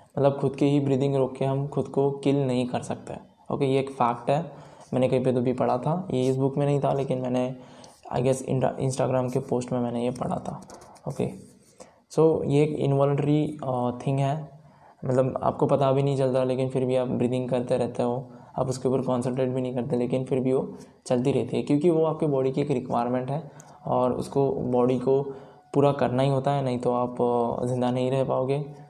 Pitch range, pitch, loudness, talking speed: 125-140 Hz, 130 Hz, -25 LUFS, 220 wpm